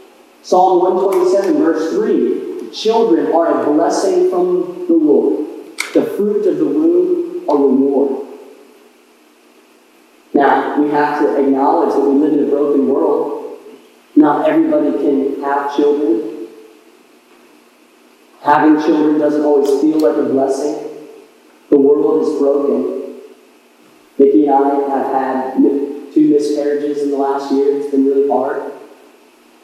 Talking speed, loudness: 125 wpm, -14 LUFS